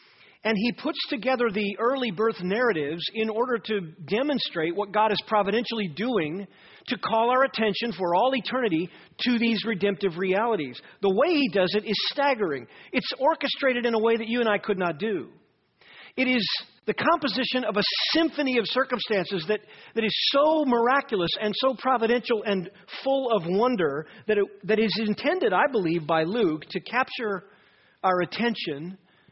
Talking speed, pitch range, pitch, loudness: 165 wpm, 200-250 Hz, 220 Hz, -25 LUFS